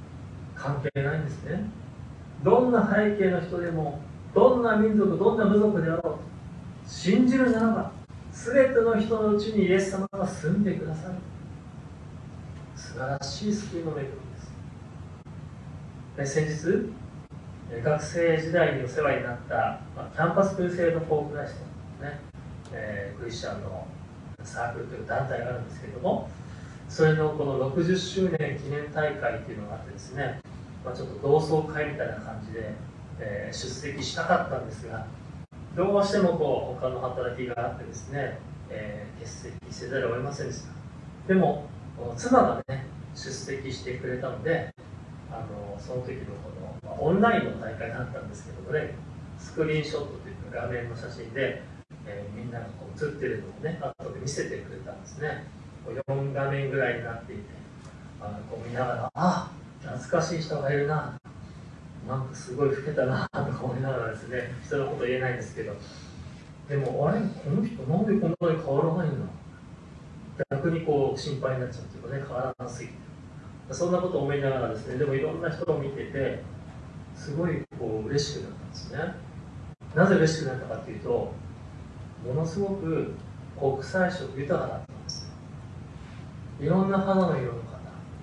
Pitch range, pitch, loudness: 125-170 Hz, 145 Hz, -28 LUFS